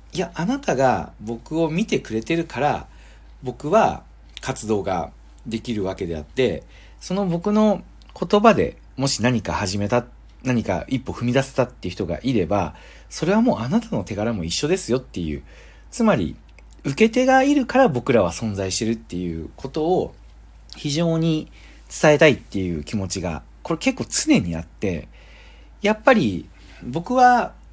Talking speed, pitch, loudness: 300 characters per minute, 120 Hz, -21 LUFS